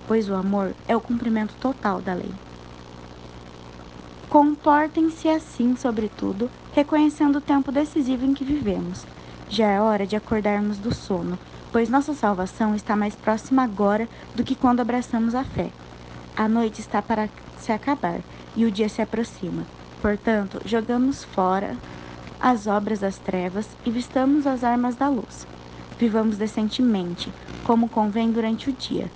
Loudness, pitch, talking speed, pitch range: -23 LUFS, 220 Hz, 145 wpm, 200-250 Hz